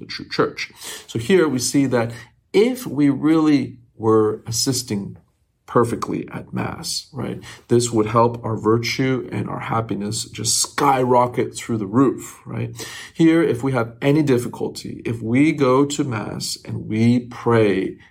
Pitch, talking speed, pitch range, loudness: 120 Hz, 150 wpm, 115-135 Hz, -20 LUFS